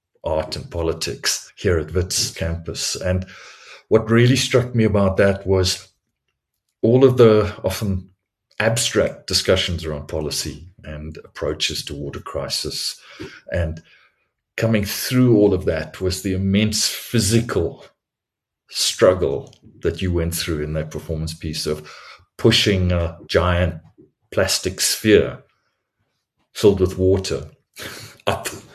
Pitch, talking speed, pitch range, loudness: 95 Hz, 120 wpm, 80-110 Hz, -20 LUFS